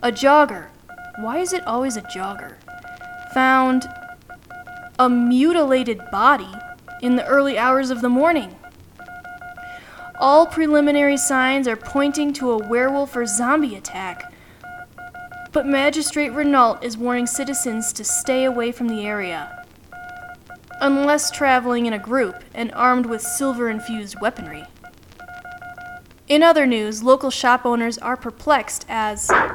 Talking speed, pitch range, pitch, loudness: 125 wpm, 240-355 Hz, 275 Hz, -19 LUFS